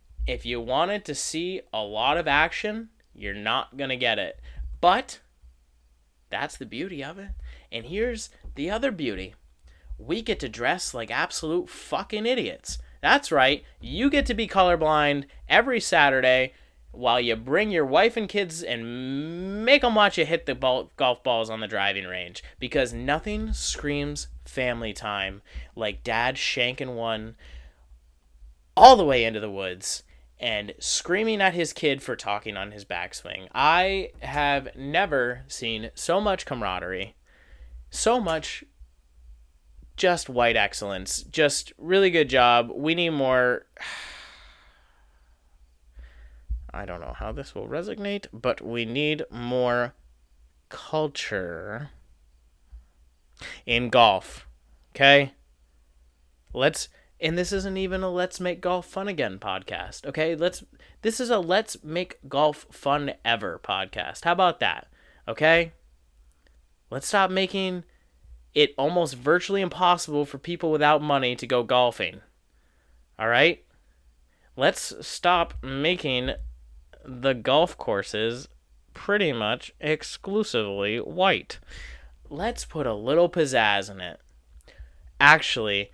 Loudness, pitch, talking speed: -24 LUFS, 120 Hz, 125 wpm